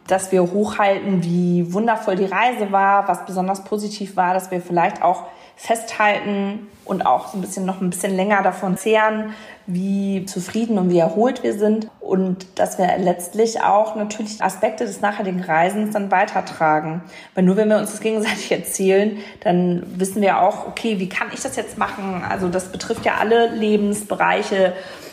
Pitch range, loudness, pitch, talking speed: 185-215 Hz, -20 LUFS, 195 Hz, 170 wpm